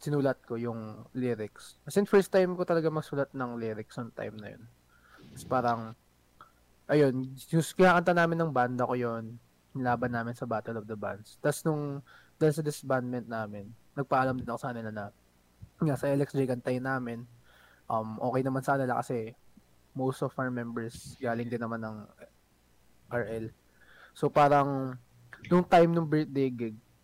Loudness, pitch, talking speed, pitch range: -30 LUFS, 125 Hz, 165 wpm, 115-140 Hz